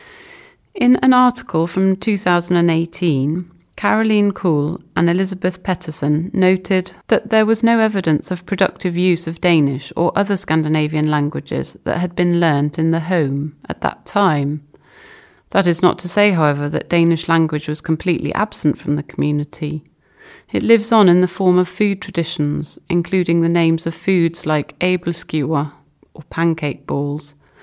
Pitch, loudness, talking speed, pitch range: 170 Hz, -17 LUFS, 155 wpm, 155-195 Hz